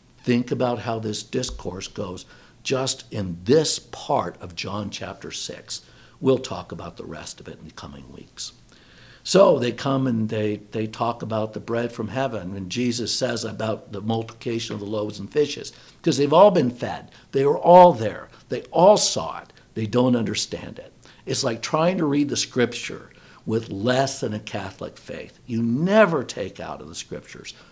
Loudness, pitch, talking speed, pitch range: -22 LUFS, 115 Hz, 185 wpm, 105-130 Hz